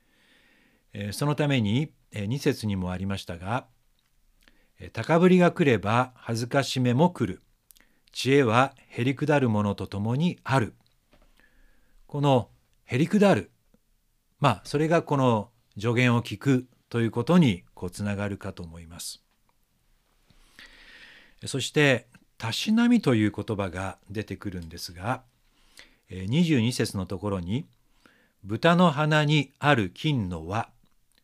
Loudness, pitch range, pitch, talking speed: -25 LUFS, 100-145 Hz, 120 Hz, 225 characters per minute